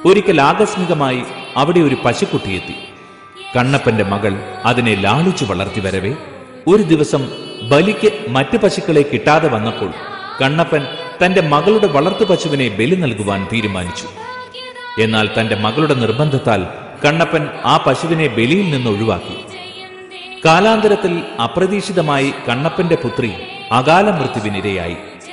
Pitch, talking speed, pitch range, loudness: 145 Hz, 100 wpm, 115-180 Hz, -15 LUFS